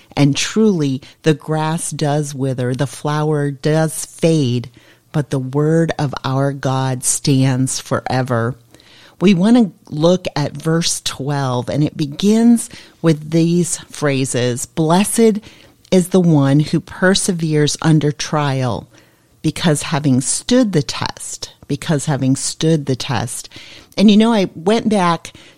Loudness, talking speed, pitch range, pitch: -16 LUFS, 130 wpm, 135-165 Hz, 150 Hz